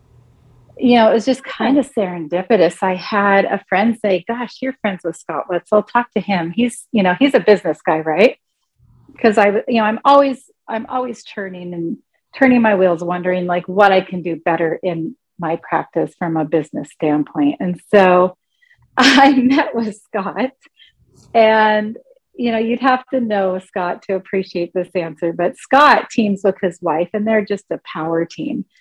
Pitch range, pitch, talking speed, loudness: 175-235 Hz, 200 Hz, 185 wpm, -16 LUFS